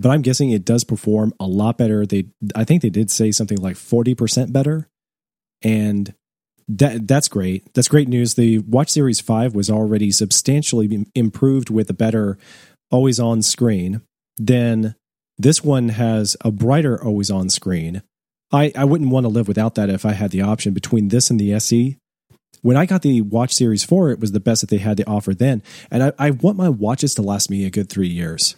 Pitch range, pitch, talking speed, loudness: 105-130 Hz, 115 Hz, 205 wpm, -17 LUFS